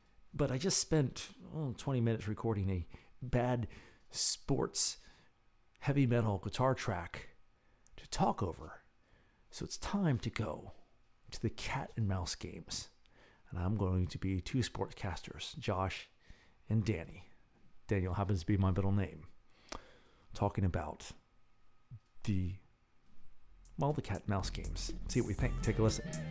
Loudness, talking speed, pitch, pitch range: -37 LUFS, 140 wpm, 110 Hz, 95-120 Hz